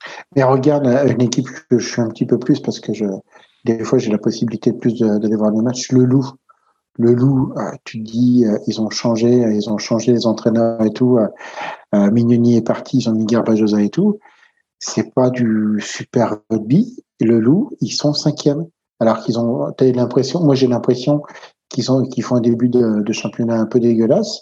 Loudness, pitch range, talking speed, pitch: -16 LUFS, 110-130 Hz, 195 wpm, 120 Hz